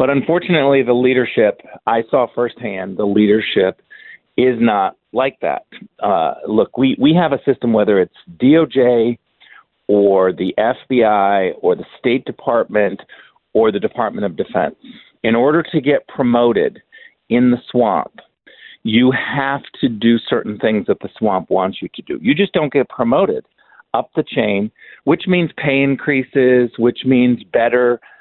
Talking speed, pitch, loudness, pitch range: 150 wpm, 125 Hz, -16 LUFS, 115-140 Hz